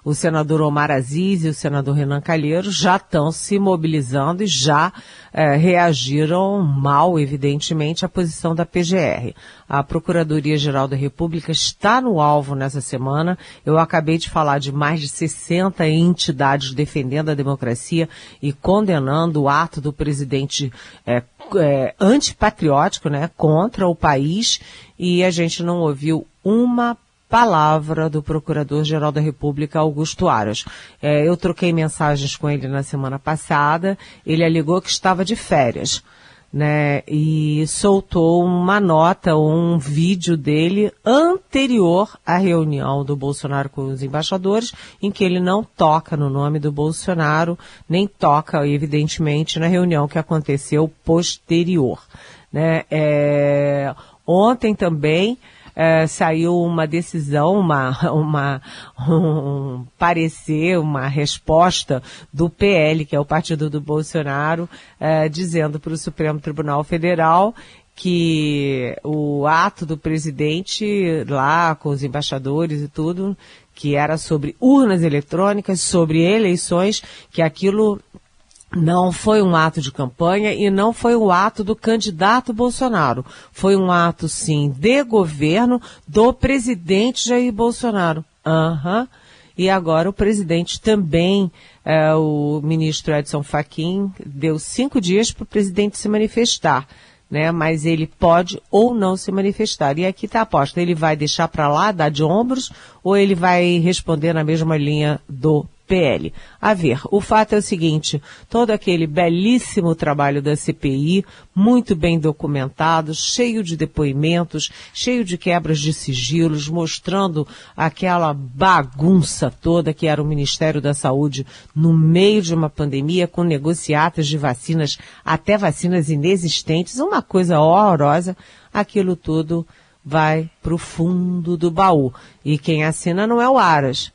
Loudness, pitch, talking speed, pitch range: -18 LUFS, 160 Hz, 135 wpm, 150-185 Hz